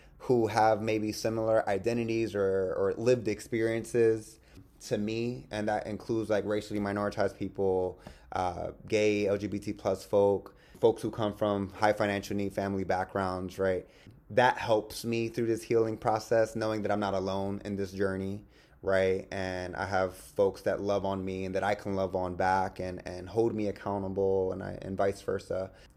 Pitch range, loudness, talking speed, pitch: 95-110 Hz, -31 LUFS, 170 wpm, 100 Hz